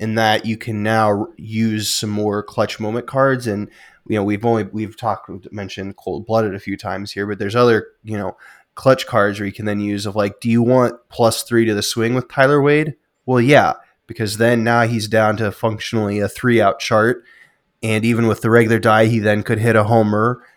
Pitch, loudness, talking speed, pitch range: 110 Hz, -17 LUFS, 220 wpm, 105-115 Hz